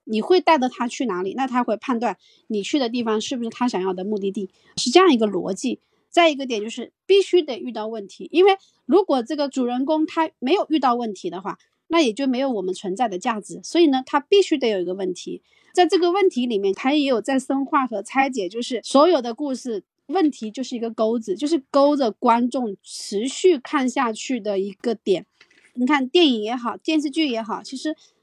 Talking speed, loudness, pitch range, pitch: 315 characters per minute, -21 LUFS, 220-310 Hz, 255 Hz